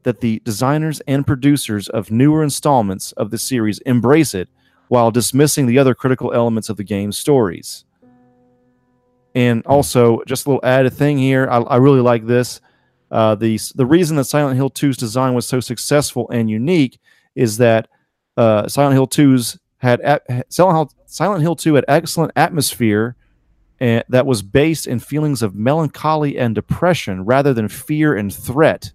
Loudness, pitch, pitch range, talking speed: -16 LUFS, 125 Hz, 115-140 Hz, 170 wpm